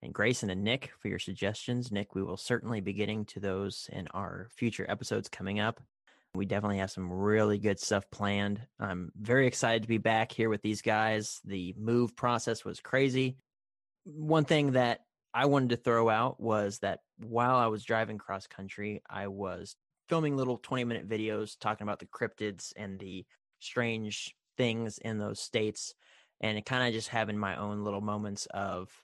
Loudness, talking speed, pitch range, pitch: -32 LUFS, 180 wpm, 100-120 Hz, 110 Hz